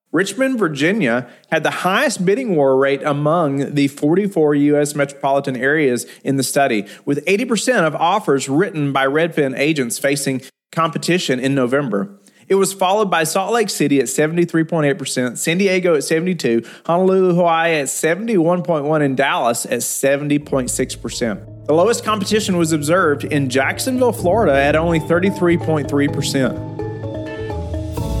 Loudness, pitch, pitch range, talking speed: -17 LUFS, 145 Hz, 135-175 Hz, 130 wpm